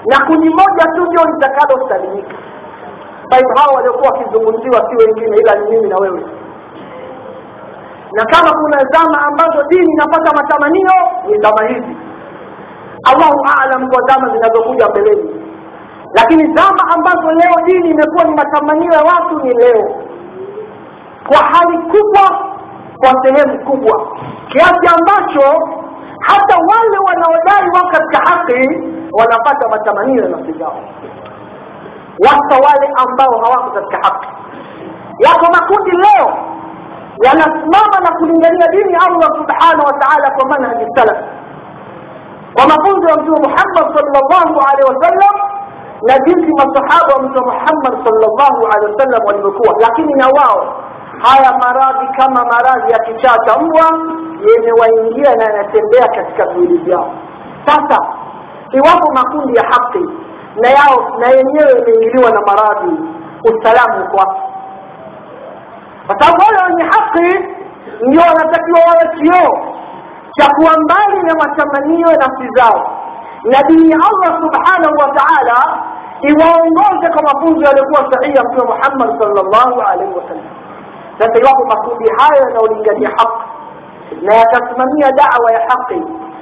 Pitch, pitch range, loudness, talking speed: 300 Hz, 255-345 Hz, -9 LUFS, 110 wpm